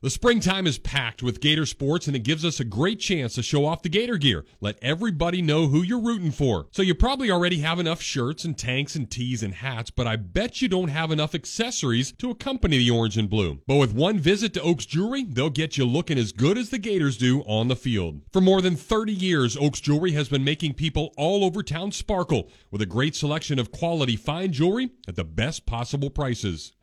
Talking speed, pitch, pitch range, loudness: 230 wpm, 150 Hz, 125-180 Hz, -24 LUFS